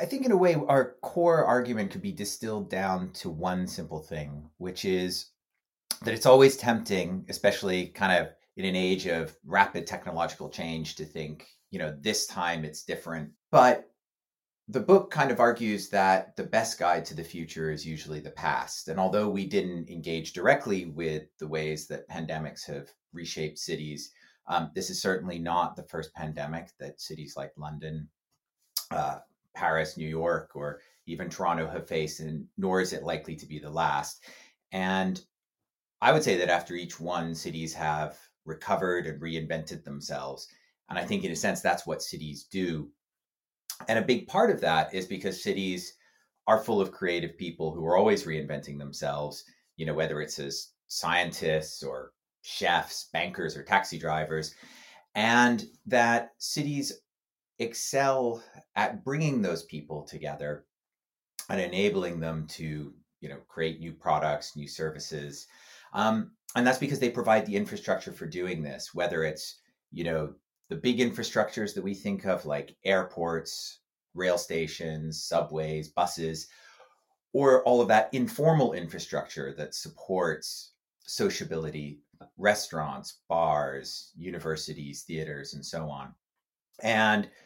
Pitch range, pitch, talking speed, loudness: 75-100 Hz, 85 Hz, 150 wpm, -29 LUFS